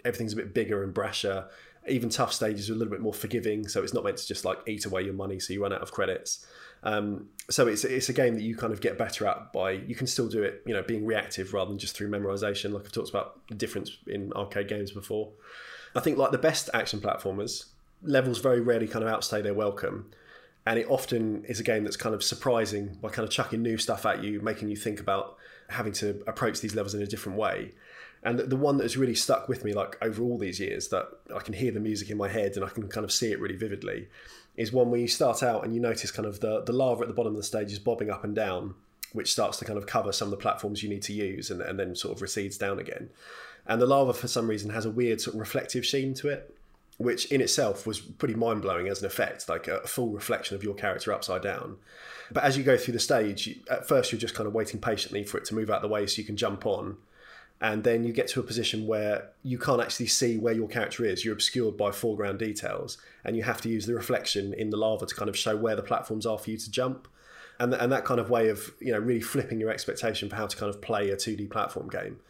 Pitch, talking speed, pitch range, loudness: 110 Hz, 270 wpm, 105-120 Hz, -29 LUFS